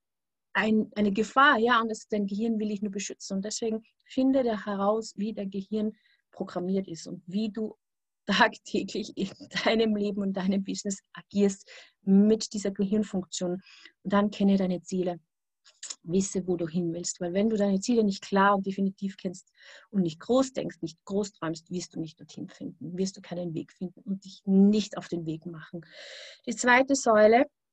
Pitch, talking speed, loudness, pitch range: 200 Hz, 180 wpm, -28 LUFS, 185-215 Hz